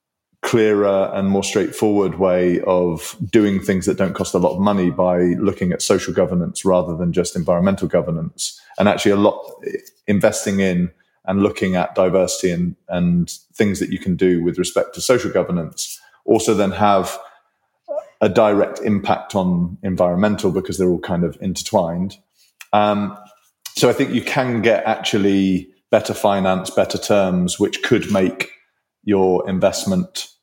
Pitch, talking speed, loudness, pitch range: 95 Hz, 155 wpm, -18 LUFS, 90-105 Hz